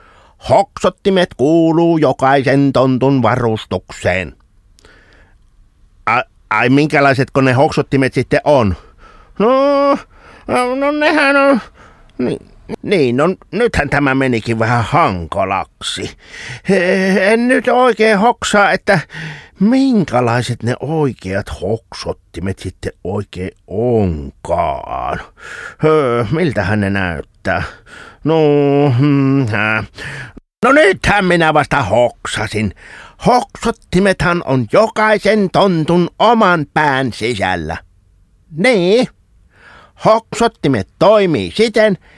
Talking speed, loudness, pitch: 85 wpm, -14 LUFS, 145 Hz